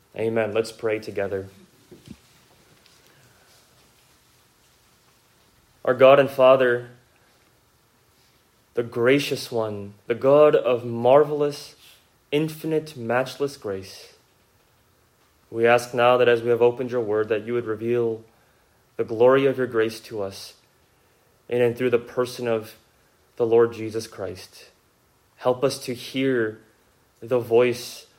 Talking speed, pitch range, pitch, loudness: 115 wpm, 115-130 Hz, 120 Hz, -22 LUFS